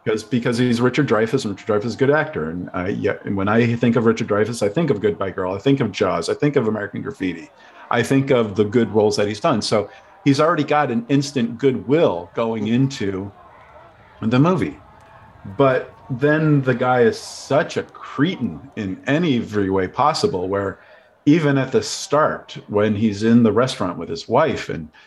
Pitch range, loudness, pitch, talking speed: 105-140 Hz, -19 LUFS, 120 Hz, 195 wpm